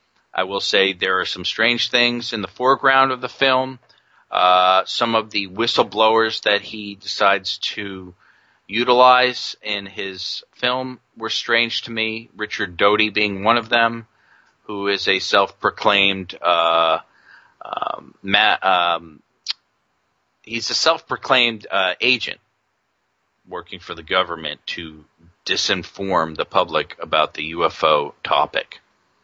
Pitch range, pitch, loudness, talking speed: 95-120 Hz, 110 Hz, -19 LUFS, 125 wpm